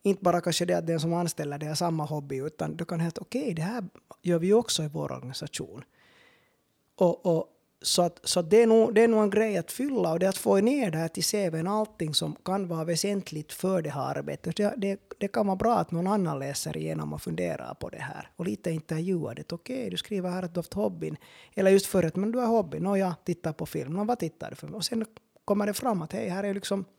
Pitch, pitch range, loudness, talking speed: 185 Hz, 165-210 Hz, -28 LUFS, 265 wpm